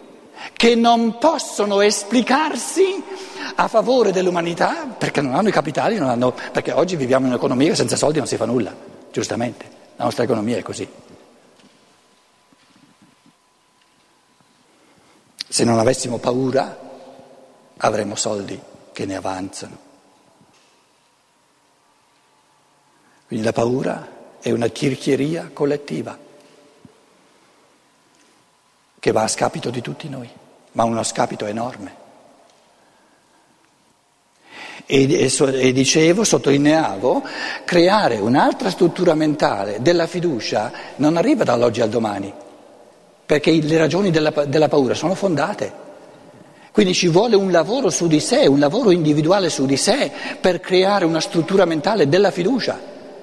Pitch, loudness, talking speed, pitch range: 160 Hz, -18 LUFS, 115 wpm, 135-195 Hz